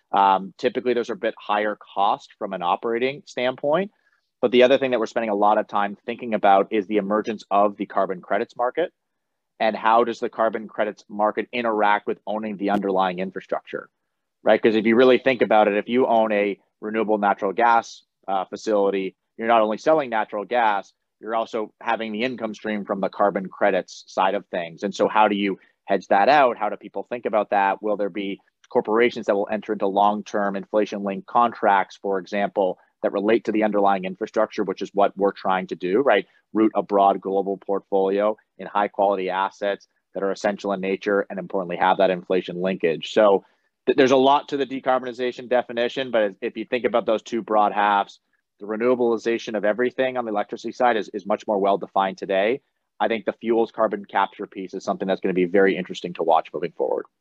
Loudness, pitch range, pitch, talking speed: -22 LUFS, 100-115 Hz, 105 Hz, 205 wpm